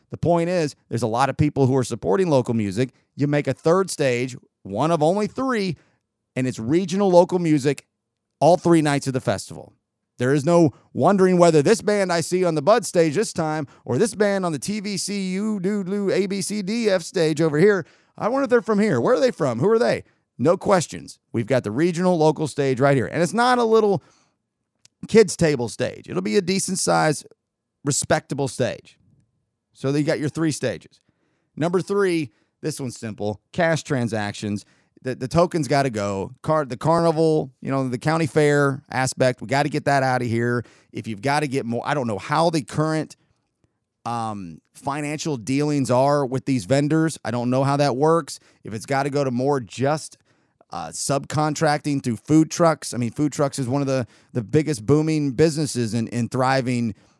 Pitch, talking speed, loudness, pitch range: 145 Hz, 195 wpm, -21 LUFS, 130-170 Hz